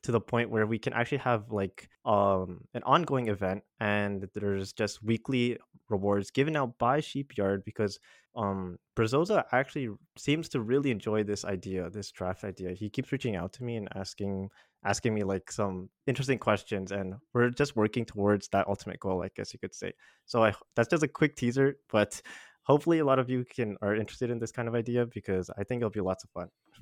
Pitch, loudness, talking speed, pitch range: 110 Hz, -31 LUFS, 205 wpm, 100-125 Hz